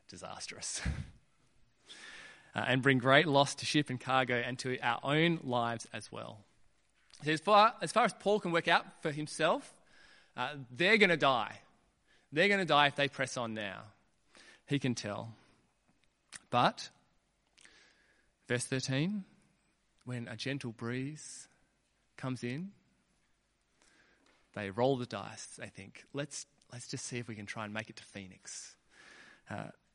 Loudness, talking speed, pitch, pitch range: -32 LUFS, 150 wpm, 130 Hz, 120-150 Hz